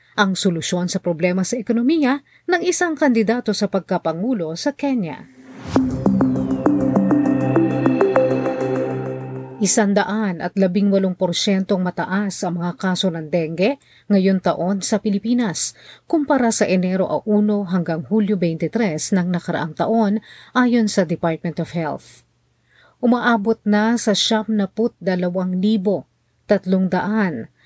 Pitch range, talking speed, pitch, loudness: 170-220 Hz, 110 wpm, 195 Hz, -19 LUFS